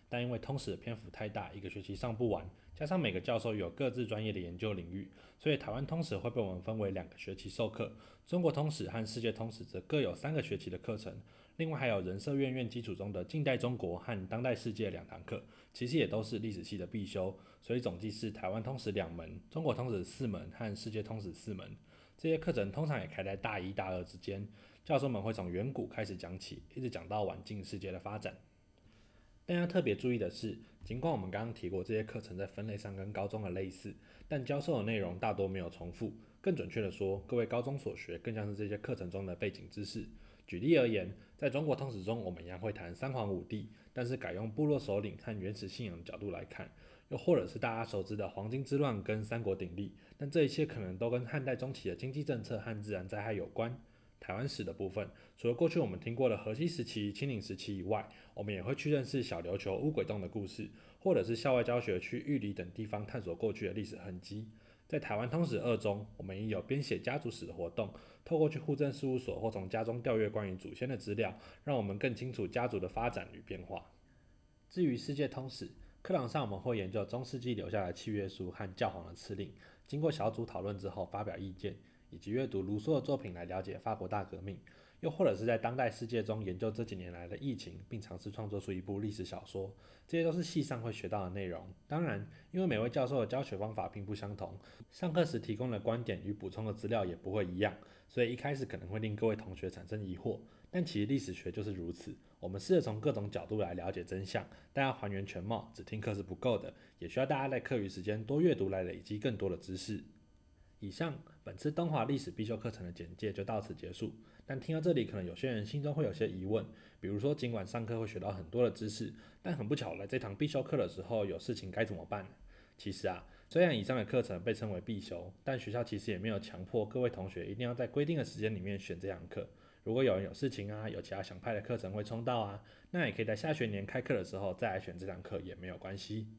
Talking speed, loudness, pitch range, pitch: 355 characters per minute, -38 LUFS, 95-125 Hz, 110 Hz